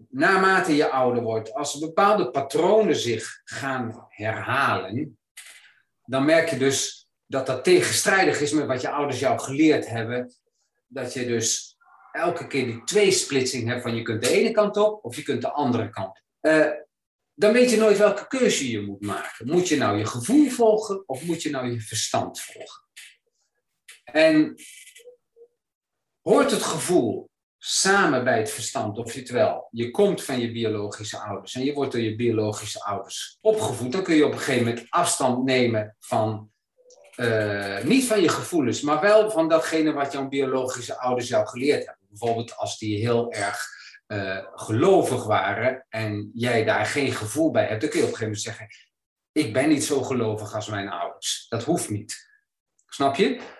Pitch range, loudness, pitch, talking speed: 115-190 Hz, -23 LUFS, 130 Hz, 180 wpm